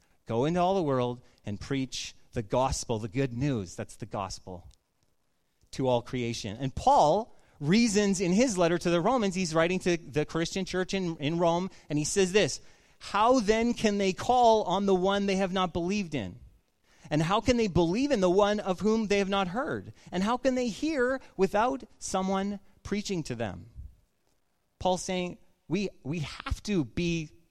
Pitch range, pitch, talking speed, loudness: 130-200 Hz, 175 Hz, 185 wpm, -28 LUFS